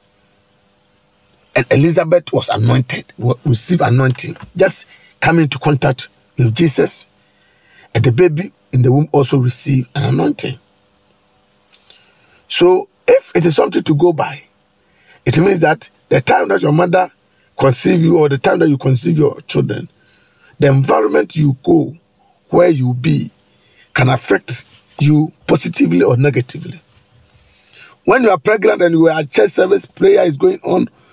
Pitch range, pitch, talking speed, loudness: 120-170 Hz, 145 Hz, 145 wpm, -14 LUFS